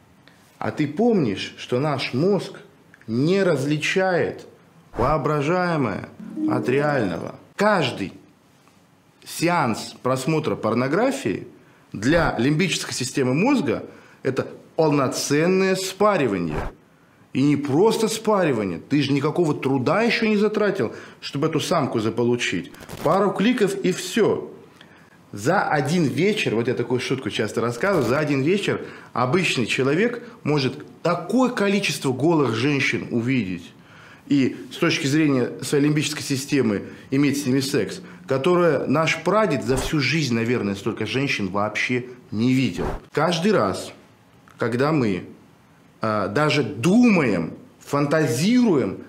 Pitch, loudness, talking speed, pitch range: 145 Hz, -22 LUFS, 110 wpm, 125-180 Hz